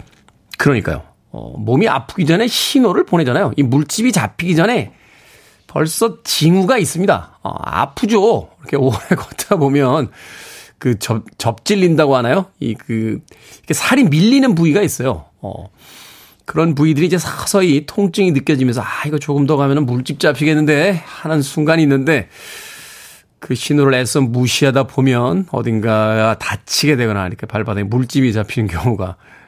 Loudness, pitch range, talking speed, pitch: -15 LUFS, 120-165 Hz, 320 characters per minute, 145 Hz